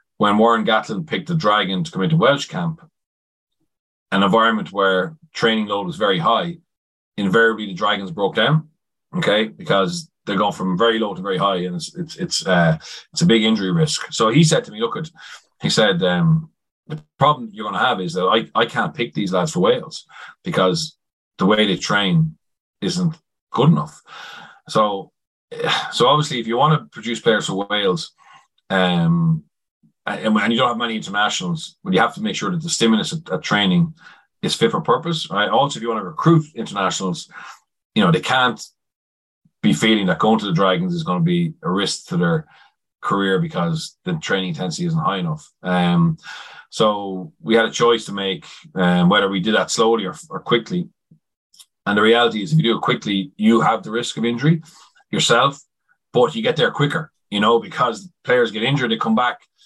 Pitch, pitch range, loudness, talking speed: 160 Hz, 115-170 Hz, -19 LUFS, 195 wpm